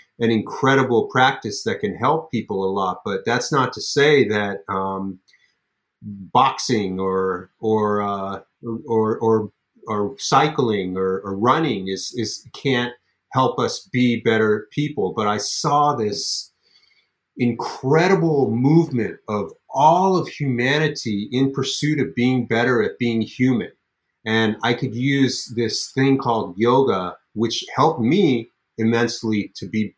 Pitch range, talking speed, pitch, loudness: 105-130 Hz, 135 wpm, 115 Hz, -20 LUFS